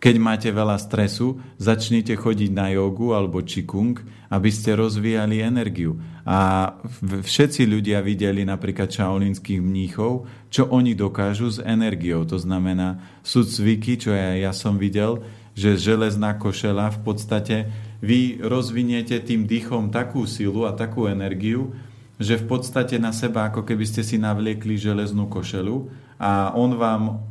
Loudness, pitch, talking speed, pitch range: -22 LUFS, 110 Hz, 140 wpm, 100-115 Hz